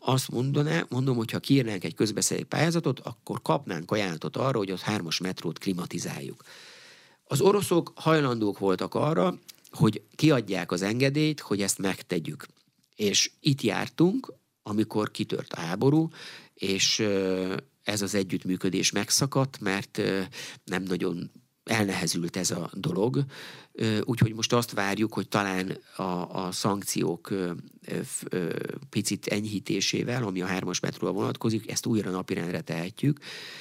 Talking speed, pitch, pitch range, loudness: 125 wpm, 110 Hz, 95-140 Hz, -28 LUFS